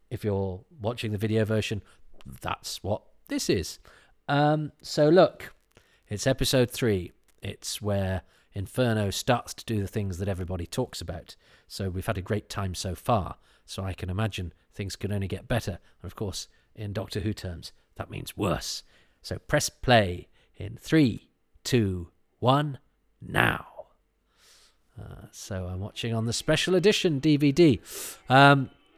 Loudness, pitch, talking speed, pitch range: -27 LUFS, 105 Hz, 150 wpm, 95-130 Hz